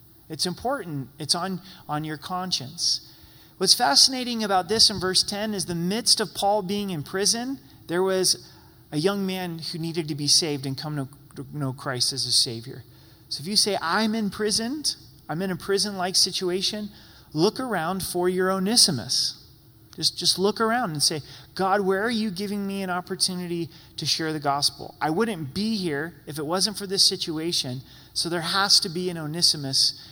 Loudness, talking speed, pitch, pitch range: -23 LUFS, 185 wpm, 180 Hz, 150-200 Hz